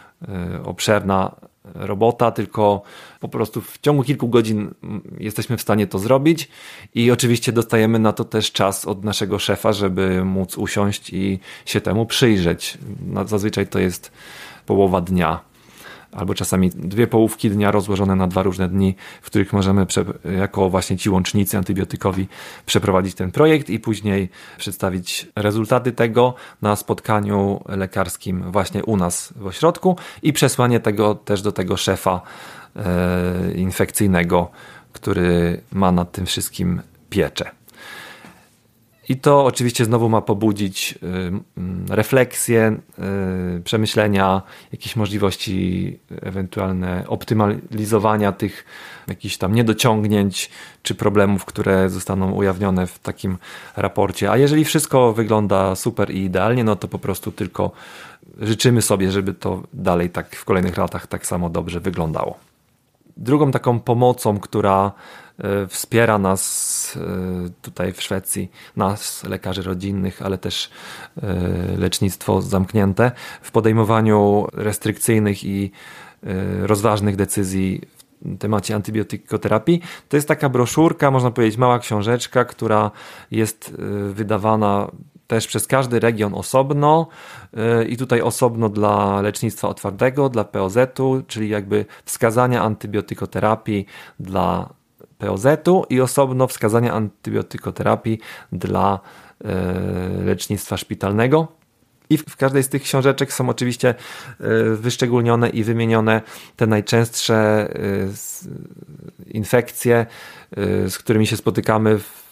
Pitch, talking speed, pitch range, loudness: 105 Hz, 115 wpm, 95-115 Hz, -19 LUFS